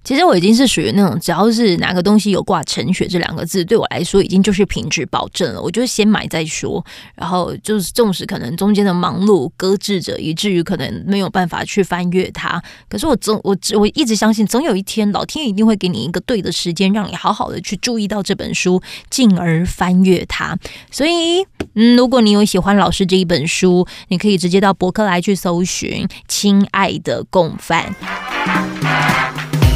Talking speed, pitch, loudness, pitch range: 300 characters per minute, 195 Hz, -15 LUFS, 180-215 Hz